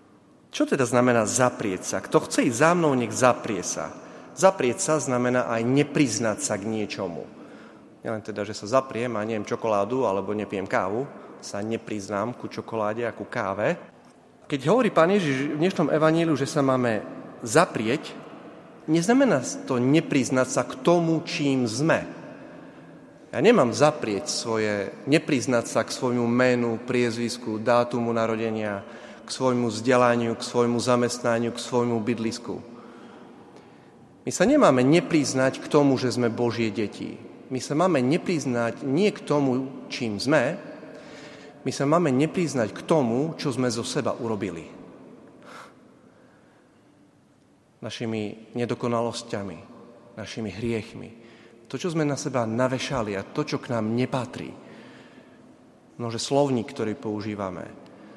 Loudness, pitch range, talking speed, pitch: -24 LUFS, 115-140 Hz, 135 wpm, 120 Hz